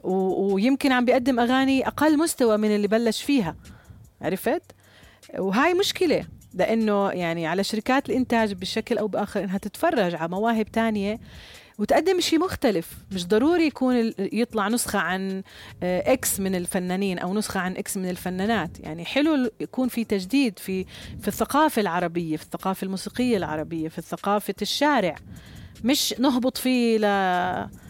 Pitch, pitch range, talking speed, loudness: 210 Hz, 185-250 Hz, 140 wpm, -24 LUFS